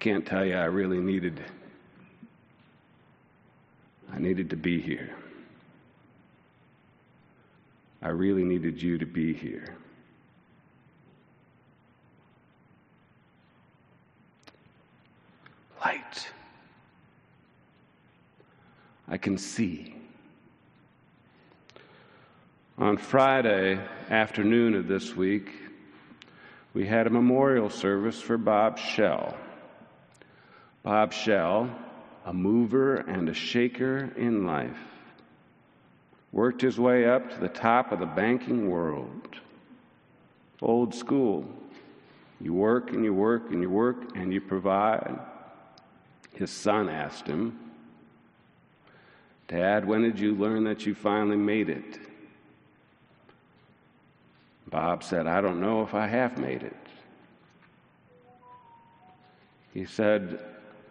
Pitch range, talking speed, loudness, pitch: 95-120 Hz, 95 wpm, -27 LUFS, 105 Hz